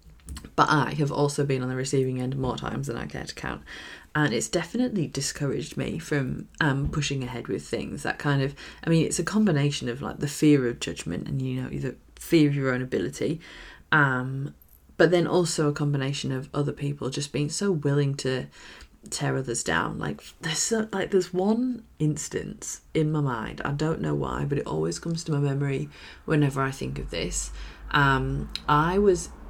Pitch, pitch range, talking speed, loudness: 140 Hz, 130-155 Hz, 195 wpm, -26 LUFS